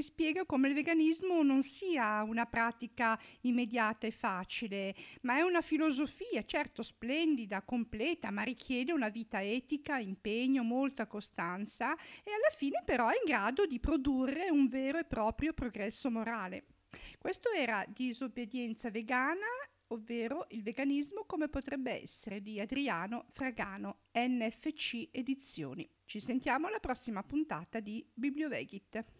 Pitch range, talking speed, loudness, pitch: 225-295 Hz, 130 wpm, -36 LUFS, 250 Hz